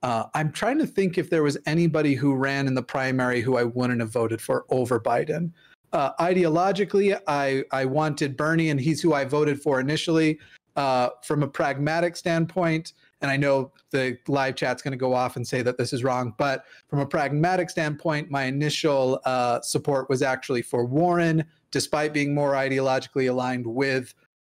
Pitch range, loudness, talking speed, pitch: 130-160 Hz, -24 LUFS, 185 wpm, 140 Hz